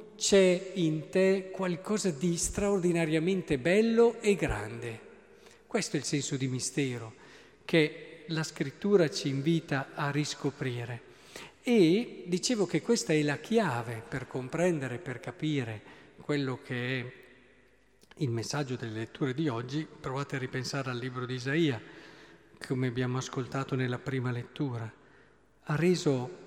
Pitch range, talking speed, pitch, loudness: 130-175 Hz, 130 wpm, 145 Hz, -31 LUFS